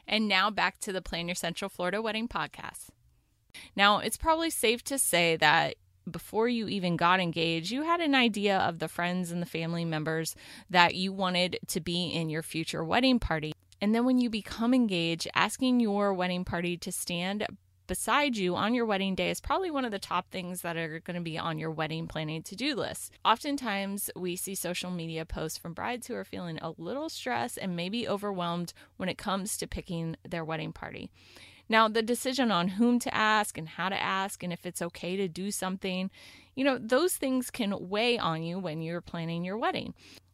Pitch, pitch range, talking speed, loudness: 185 Hz, 170-220 Hz, 205 wpm, -30 LUFS